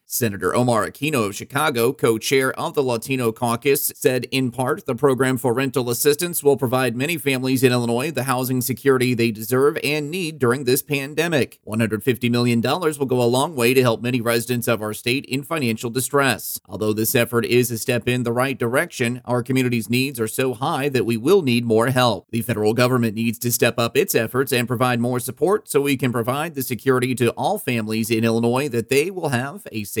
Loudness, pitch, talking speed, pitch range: -20 LUFS, 125 Hz, 210 wpm, 115-135 Hz